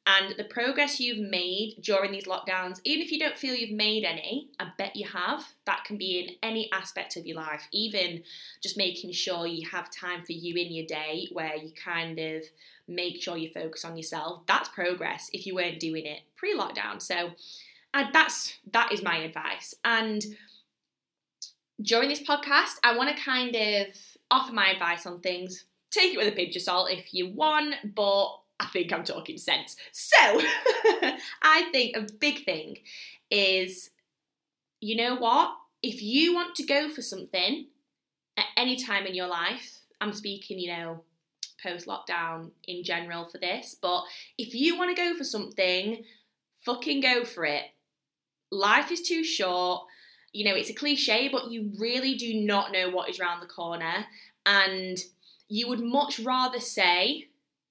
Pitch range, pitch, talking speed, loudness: 175-250 Hz, 200 Hz, 175 wpm, -27 LUFS